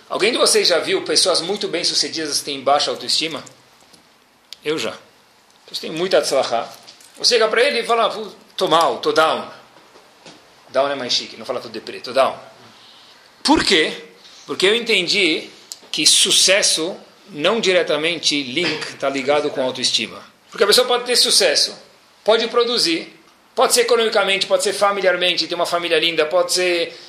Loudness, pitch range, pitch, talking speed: -17 LUFS, 155-235 Hz, 180 Hz, 160 wpm